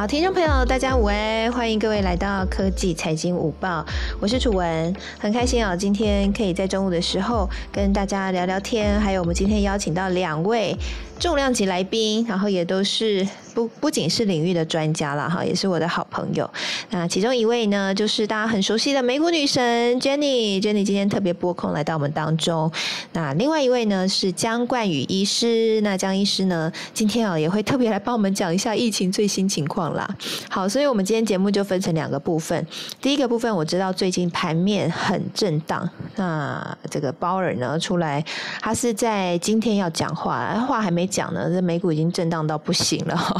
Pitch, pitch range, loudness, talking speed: 195 Hz, 175-220 Hz, -22 LUFS, 320 characters per minute